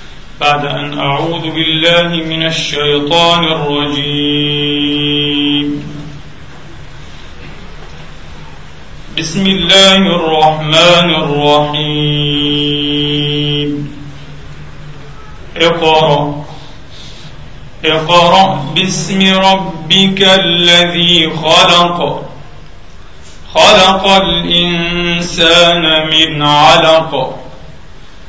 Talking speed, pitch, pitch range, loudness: 45 wpm, 150 Hz, 145-170 Hz, -9 LUFS